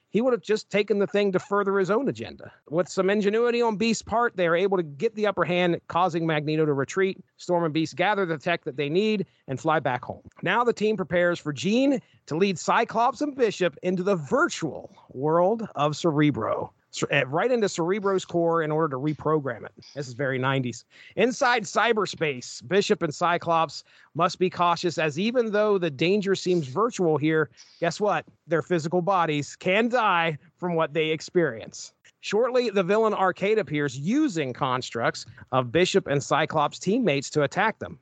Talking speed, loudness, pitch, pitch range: 180 wpm, -25 LUFS, 175 Hz, 155-205 Hz